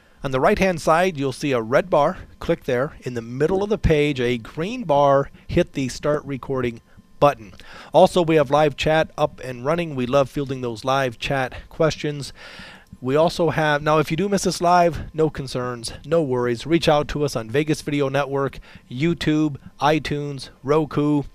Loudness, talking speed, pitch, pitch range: -21 LUFS, 185 wpm, 145 Hz, 130-155 Hz